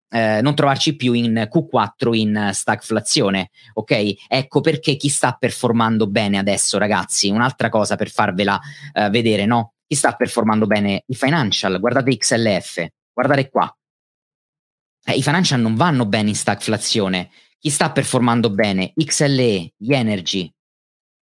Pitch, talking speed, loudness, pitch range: 115 Hz, 140 wpm, -18 LUFS, 105-135 Hz